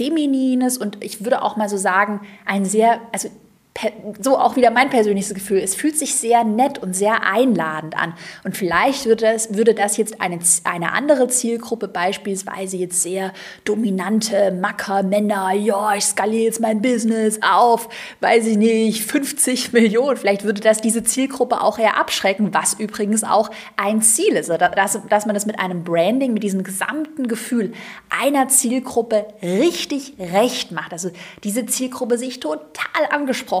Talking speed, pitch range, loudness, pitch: 165 wpm, 200-245 Hz, -18 LUFS, 220 Hz